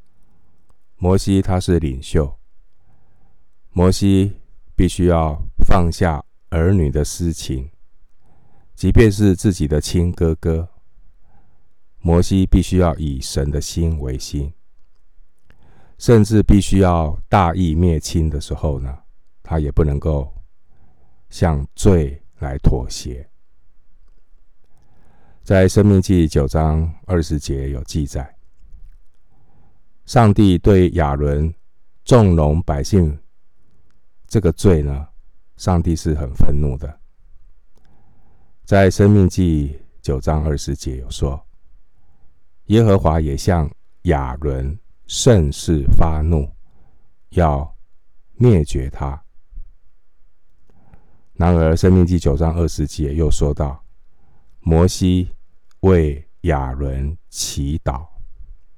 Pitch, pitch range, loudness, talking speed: 80 Hz, 75-90 Hz, -17 LUFS, 140 characters per minute